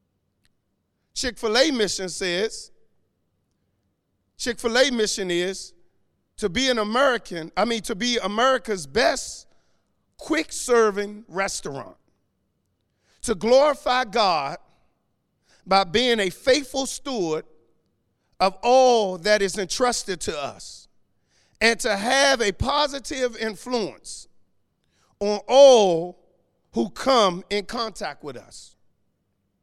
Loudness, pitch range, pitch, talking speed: -22 LUFS, 185-255 Hz, 215 Hz, 105 wpm